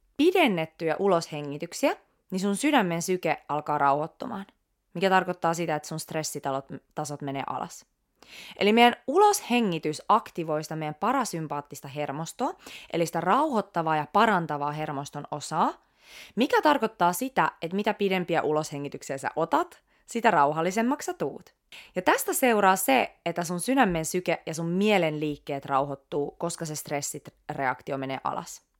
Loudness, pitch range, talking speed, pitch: -27 LUFS, 150-210 Hz, 130 wpm, 170 Hz